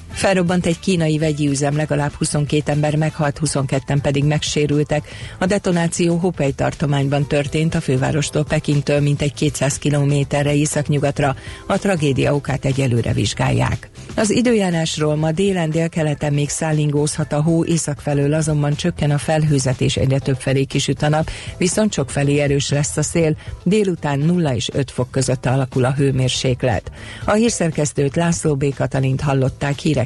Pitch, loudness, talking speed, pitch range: 145 Hz, -18 LUFS, 145 wpm, 140-160 Hz